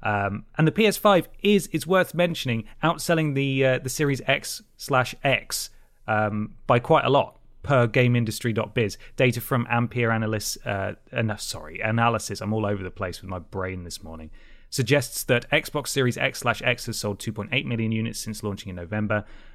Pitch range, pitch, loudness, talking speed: 105-135 Hz, 120 Hz, -24 LUFS, 170 wpm